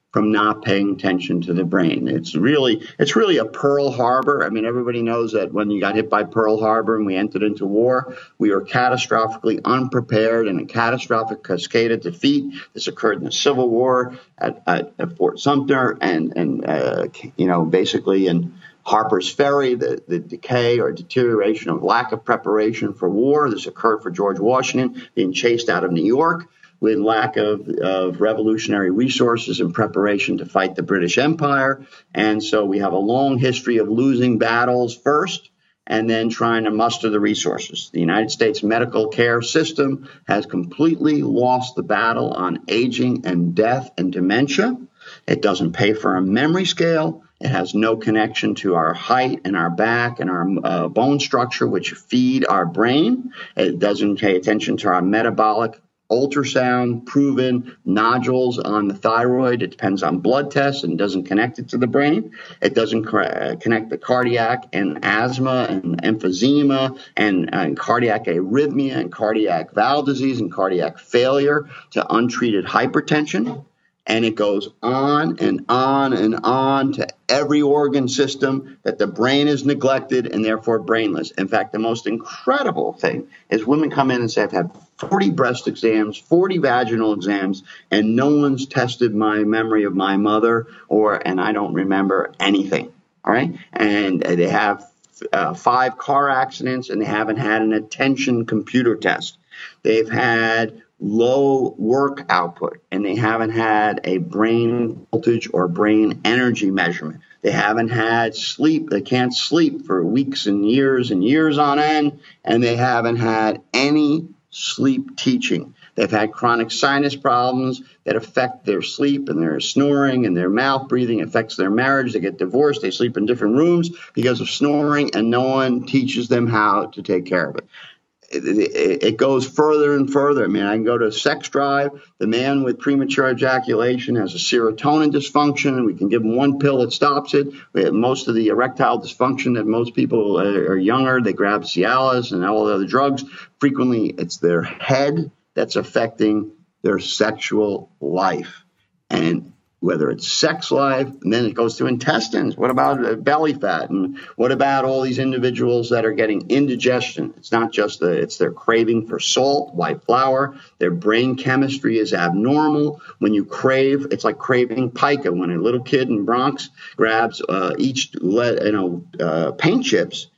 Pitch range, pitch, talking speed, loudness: 110-140 Hz, 125 Hz, 170 wpm, -19 LUFS